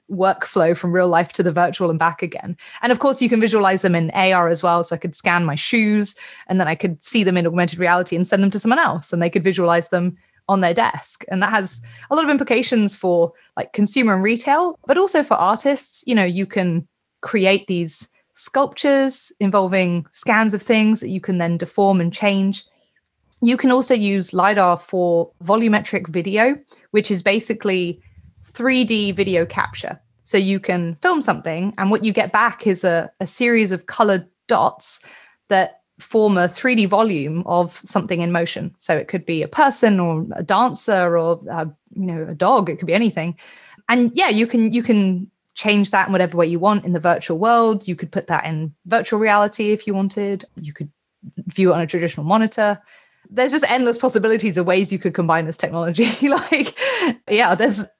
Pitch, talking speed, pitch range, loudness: 195 Hz, 200 wpm, 175-220 Hz, -18 LUFS